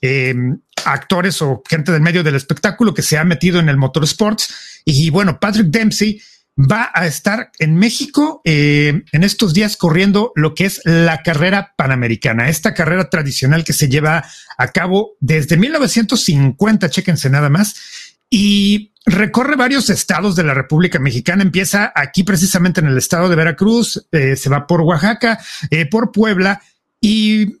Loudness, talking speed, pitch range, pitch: -14 LUFS, 160 wpm, 155-210 Hz, 180 Hz